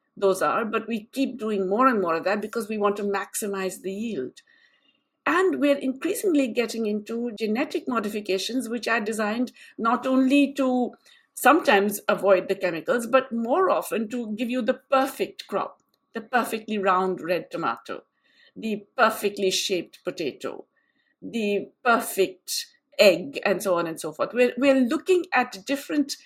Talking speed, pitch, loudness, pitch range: 155 wpm, 230 Hz, -24 LUFS, 205-270 Hz